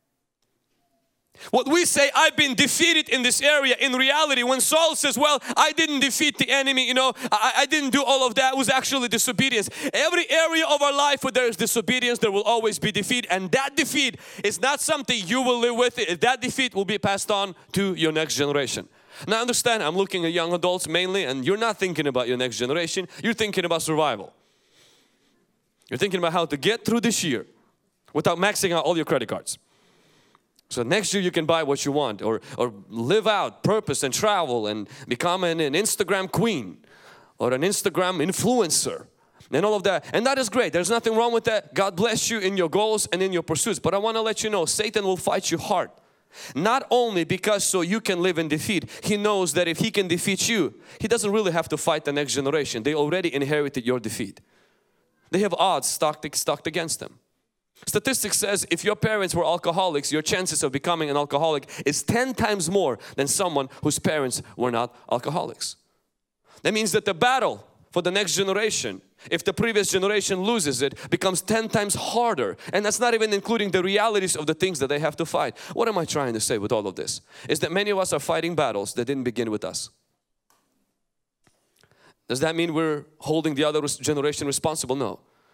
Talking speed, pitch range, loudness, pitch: 205 wpm, 160-235 Hz, -23 LUFS, 195 Hz